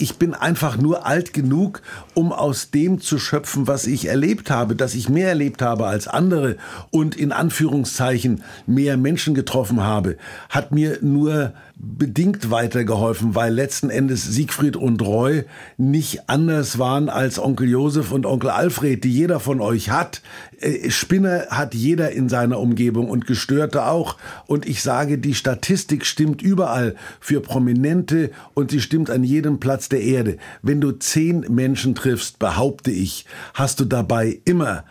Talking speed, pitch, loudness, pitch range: 155 wpm, 135 Hz, -20 LUFS, 120-150 Hz